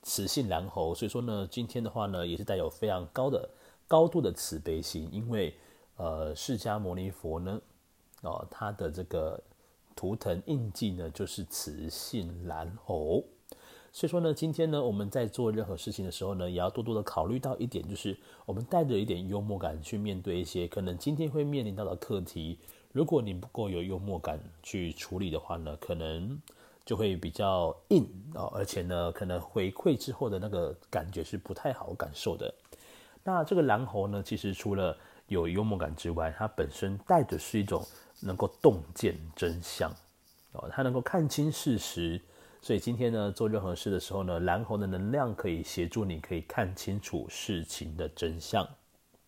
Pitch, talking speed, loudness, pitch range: 100 Hz, 270 characters per minute, -33 LUFS, 85-120 Hz